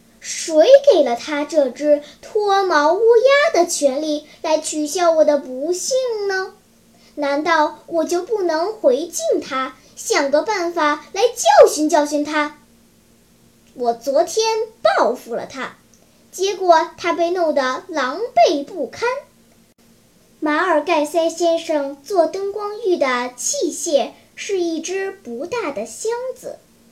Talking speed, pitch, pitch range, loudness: 175 characters per minute, 320 Hz, 295-385 Hz, -18 LUFS